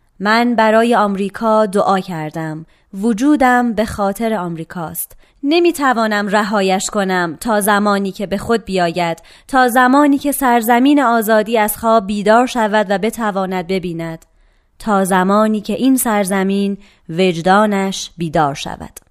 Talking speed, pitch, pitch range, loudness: 120 wpm, 210 Hz, 190-230 Hz, -15 LUFS